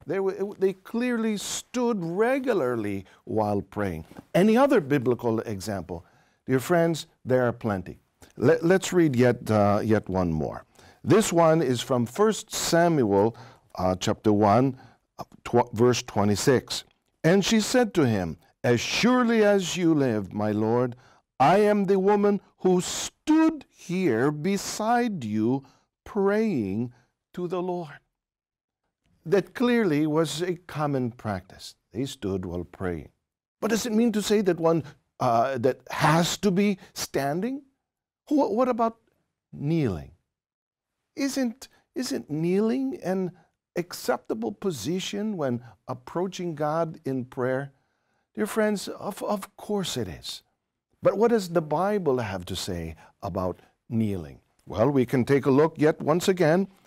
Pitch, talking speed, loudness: 155 Hz, 135 wpm, -25 LUFS